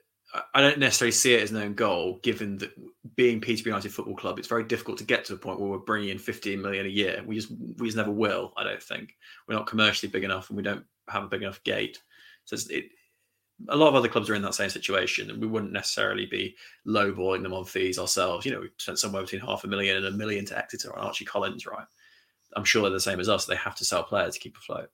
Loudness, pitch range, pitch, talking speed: -27 LUFS, 95-115 Hz, 105 Hz, 265 wpm